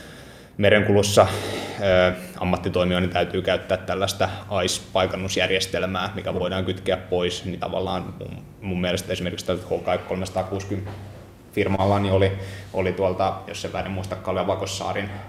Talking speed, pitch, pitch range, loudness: 100 wpm, 95 Hz, 90-100 Hz, -23 LUFS